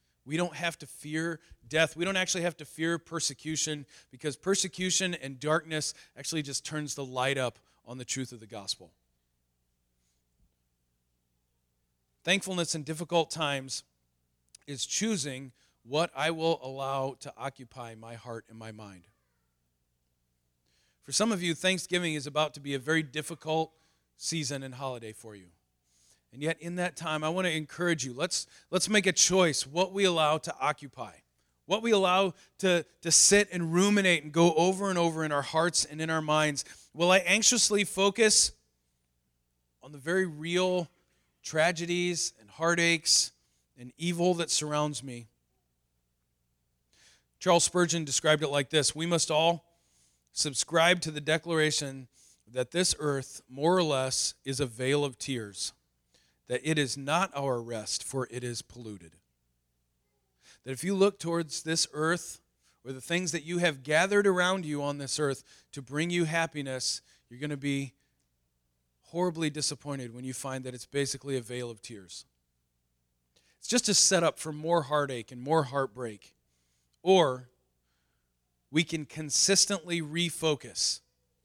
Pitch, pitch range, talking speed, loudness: 145 Hz, 100-170 Hz, 150 wpm, -29 LUFS